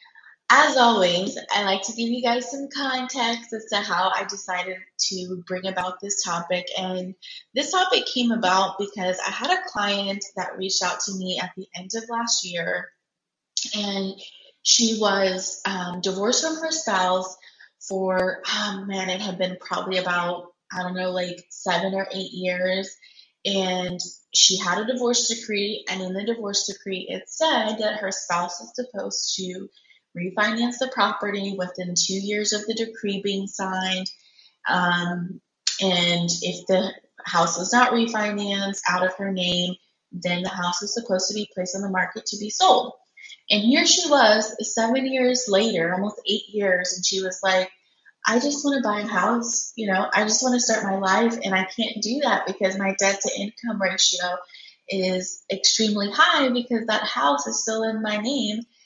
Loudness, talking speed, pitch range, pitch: -23 LUFS, 175 wpm, 185-225 Hz, 195 Hz